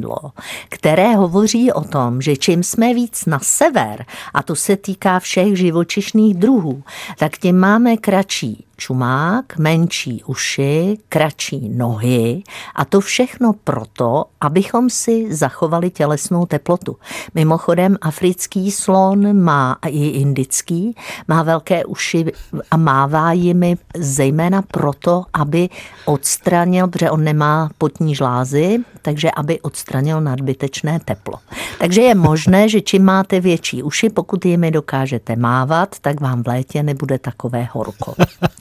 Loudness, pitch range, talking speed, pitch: -16 LUFS, 145-190 Hz, 125 wpm, 165 Hz